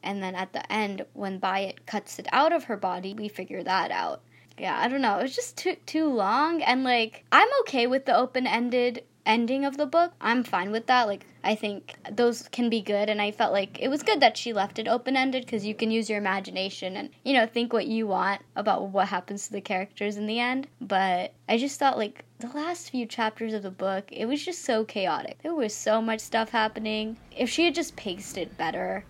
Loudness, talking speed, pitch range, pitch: -27 LUFS, 235 wpm, 200-260 Hz, 225 Hz